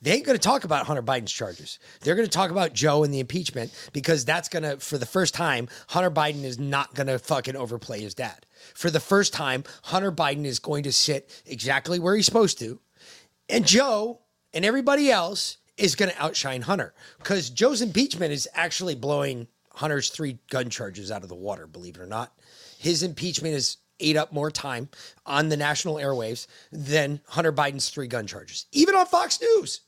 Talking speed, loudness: 200 wpm, -25 LUFS